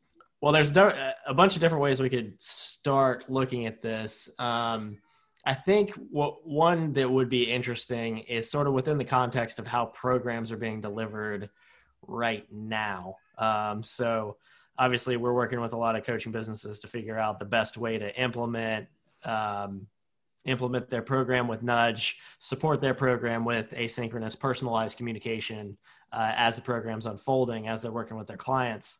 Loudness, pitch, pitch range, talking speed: -28 LUFS, 115 Hz, 110-130 Hz, 165 wpm